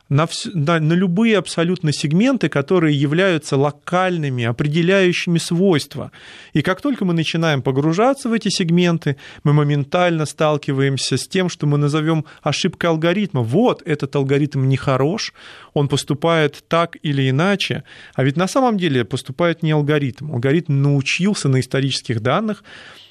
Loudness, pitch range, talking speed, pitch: -18 LUFS, 140-180 Hz, 140 wpm, 155 Hz